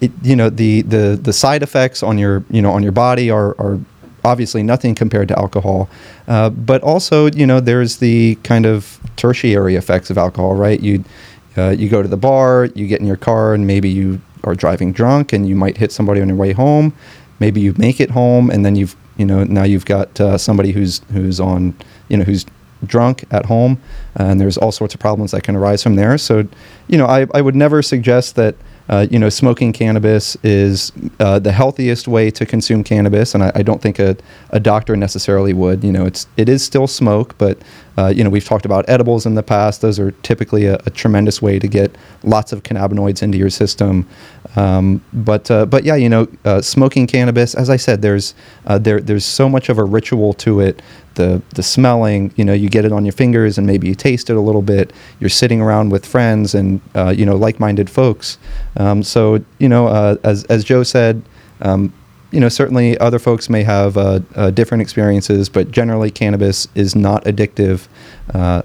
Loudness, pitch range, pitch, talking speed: -13 LUFS, 100-120 Hz, 105 Hz, 215 wpm